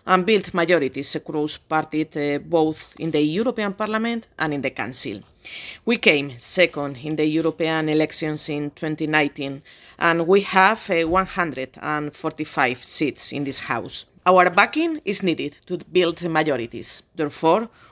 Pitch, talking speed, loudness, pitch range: 160 Hz, 135 wpm, -22 LUFS, 150-180 Hz